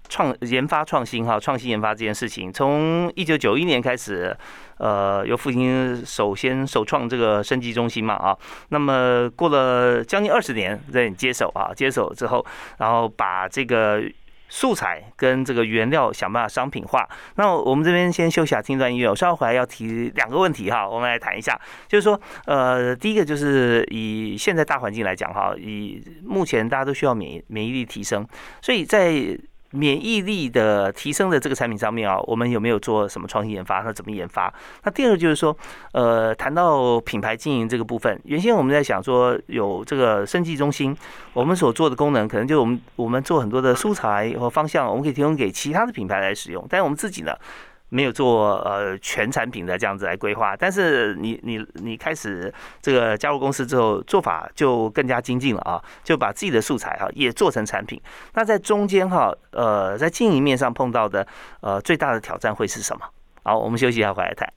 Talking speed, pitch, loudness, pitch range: 315 characters per minute, 125 Hz, -21 LUFS, 110-150 Hz